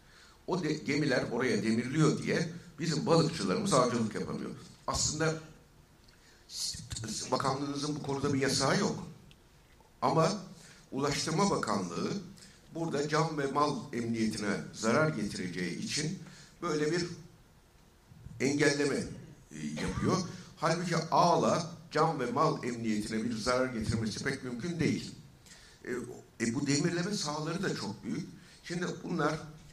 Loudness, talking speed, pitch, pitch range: -32 LUFS, 110 wpm, 150 Hz, 130-165 Hz